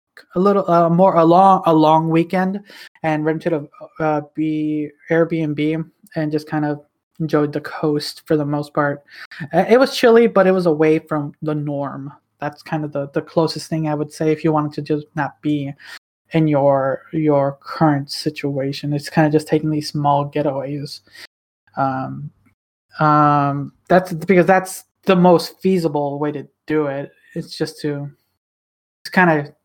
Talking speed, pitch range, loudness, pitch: 170 wpm, 145-165 Hz, -18 LUFS, 155 Hz